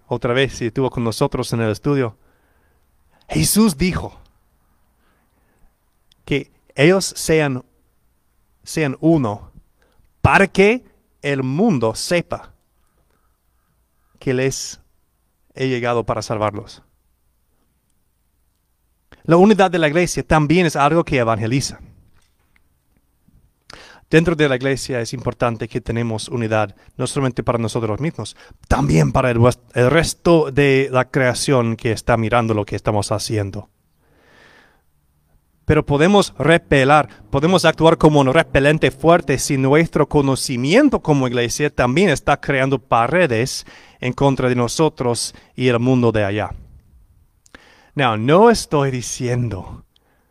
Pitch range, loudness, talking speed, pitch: 105-150 Hz, -17 LUFS, 115 wpm, 125 Hz